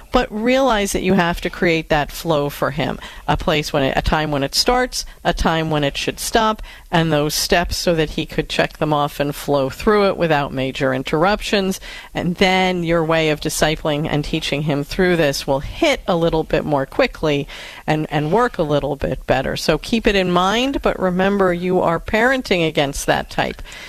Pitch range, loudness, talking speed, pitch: 150-195 Hz, -18 LUFS, 205 wpm, 165 Hz